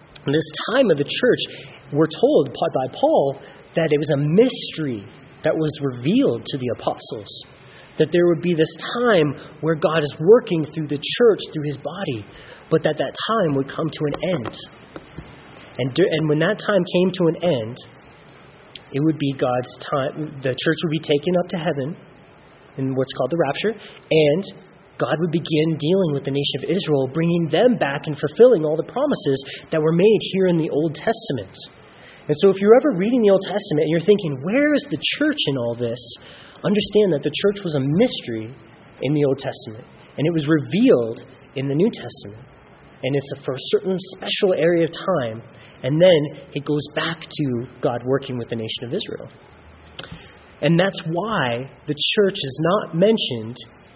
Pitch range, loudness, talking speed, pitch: 140-185 Hz, -20 LUFS, 185 wpm, 155 Hz